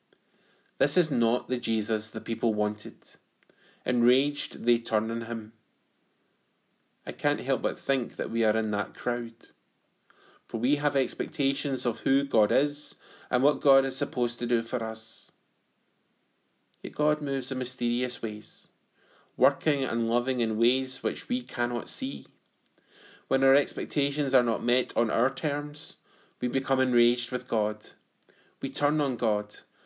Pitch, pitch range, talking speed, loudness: 125 Hz, 115-135 Hz, 150 wpm, -28 LUFS